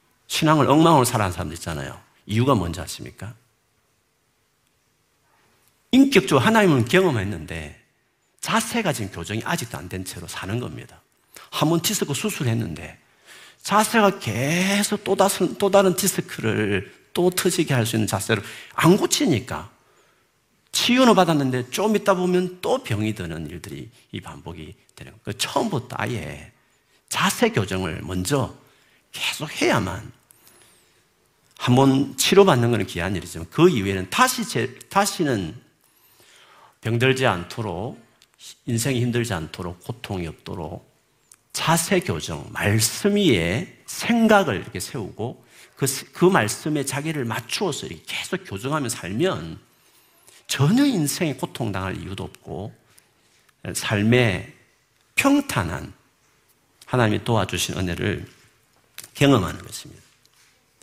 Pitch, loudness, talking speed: 125 Hz, -22 LUFS, 265 characters per minute